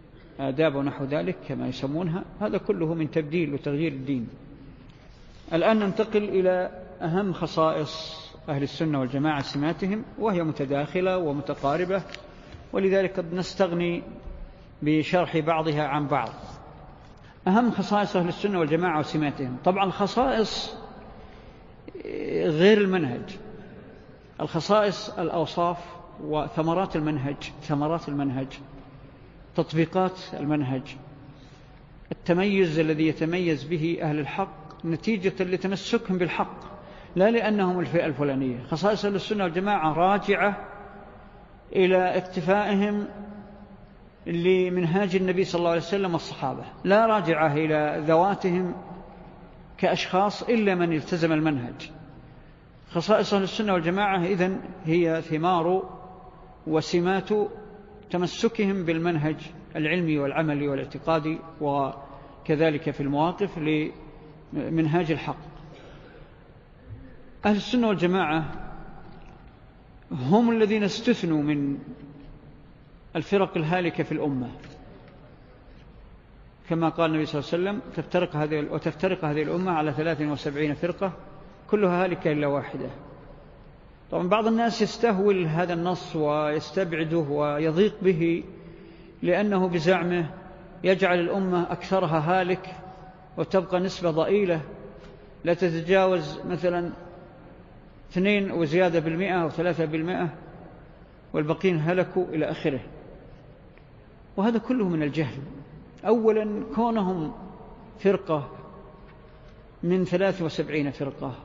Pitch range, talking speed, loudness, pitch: 150-190 Hz, 90 wpm, -25 LUFS, 170 Hz